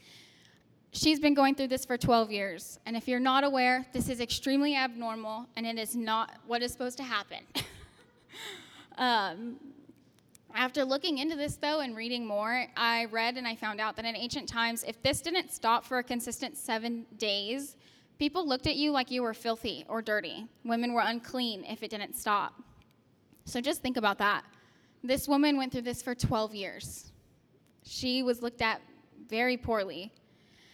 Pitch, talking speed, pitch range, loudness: 240 Hz, 175 wpm, 225-265 Hz, -31 LUFS